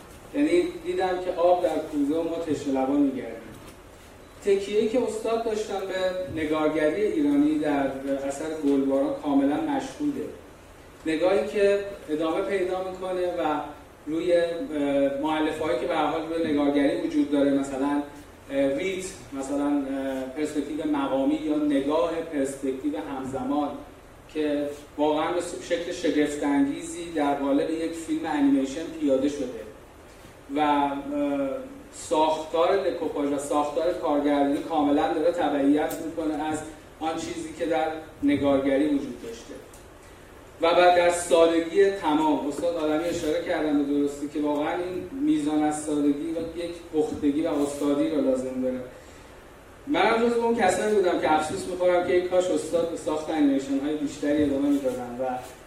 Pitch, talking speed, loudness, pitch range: 160 Hz, 130 wpm, -25 LUFS, 145-185 Hz